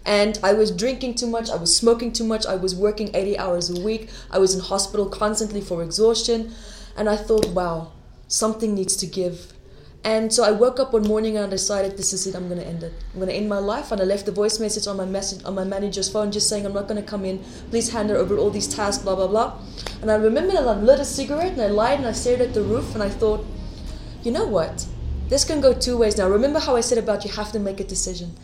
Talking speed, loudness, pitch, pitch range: 265 wpm, -22 LUFS, 210 Hz, 190-225 Hz